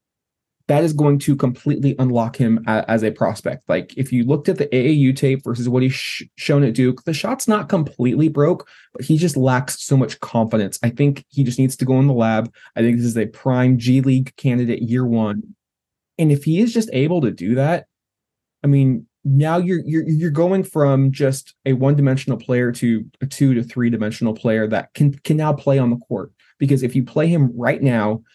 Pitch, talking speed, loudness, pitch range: 130 Hz, 215 wpm, -18 LUFS, 120-145 Hz